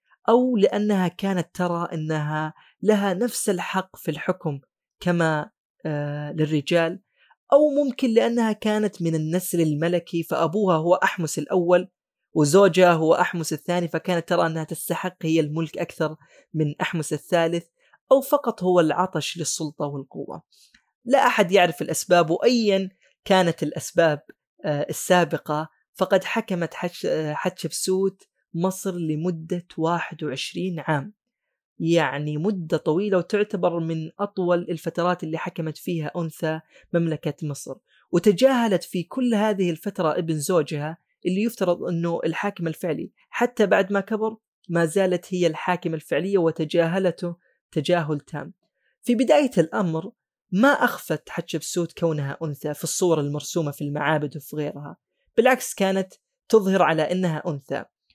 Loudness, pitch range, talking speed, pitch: -23 LUFS, 160-195 Hz, 120 wpm, 175 Hz